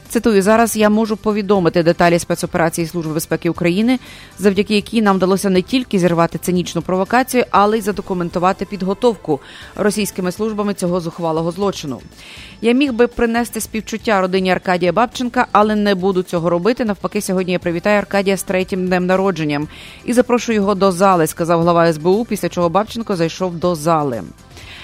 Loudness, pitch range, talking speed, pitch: -16 LUFS, 175-210 Hz, 155 wpm, 190 Hz